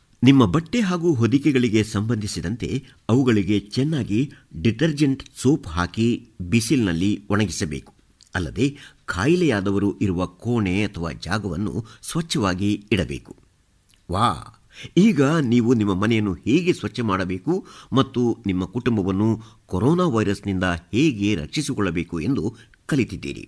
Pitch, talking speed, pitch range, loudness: 110 Hz, 95 wpm, 100-135 Hz, -22 LUFS